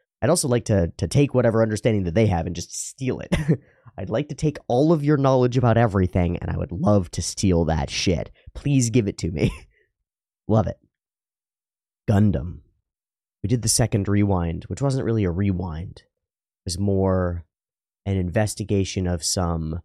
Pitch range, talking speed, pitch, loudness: 90-120 Hz, 175 wpm, 100 Hz, -22 LUFS